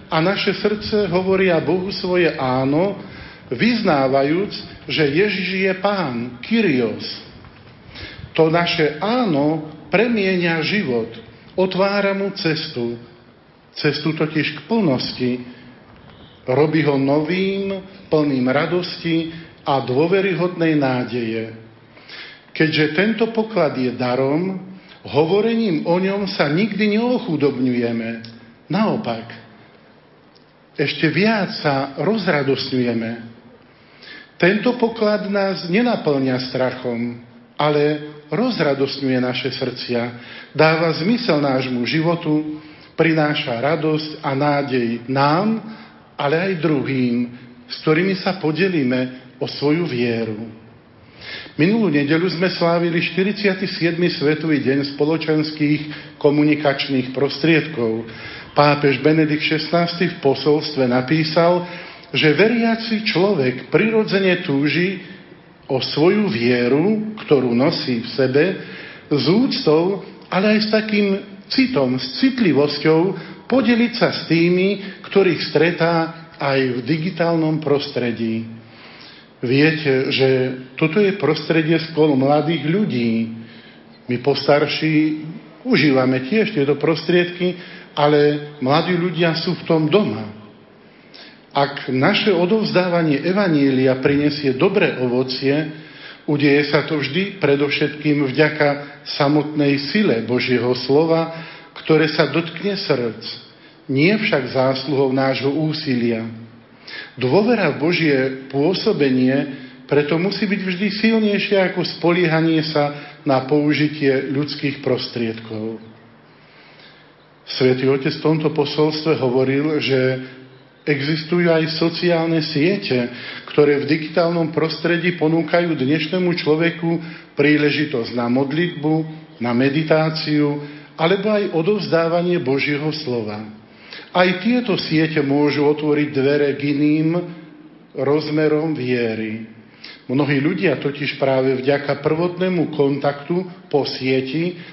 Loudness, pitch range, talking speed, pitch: -18 LUFS, 135-175 Hz, 95 wpm, 150 Hz